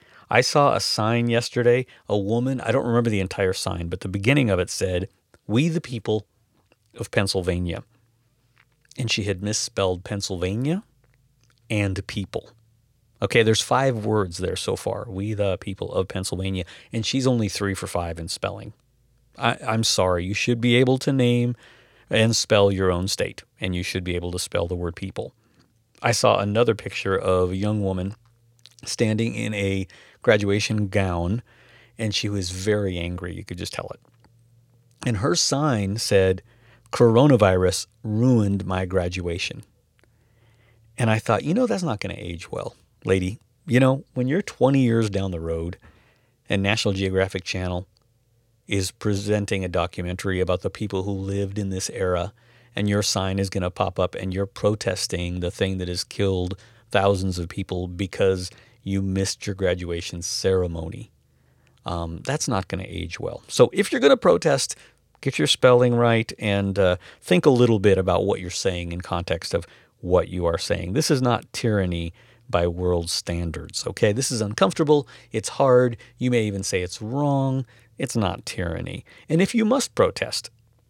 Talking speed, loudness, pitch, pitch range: 170 wpm, -23 LUFS, 105 Hz, 95-120 Hz